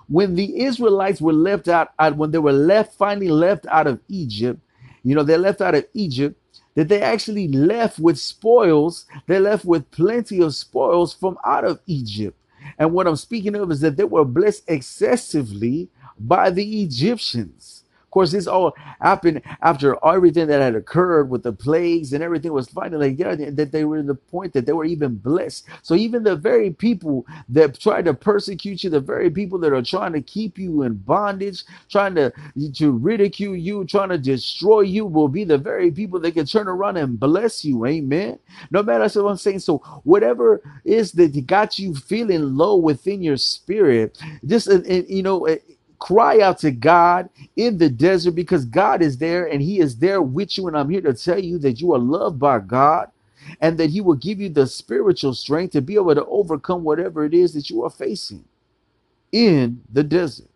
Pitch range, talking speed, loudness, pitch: 145-195 Hz, 200 wpm, -19 LUFS, 170 Hz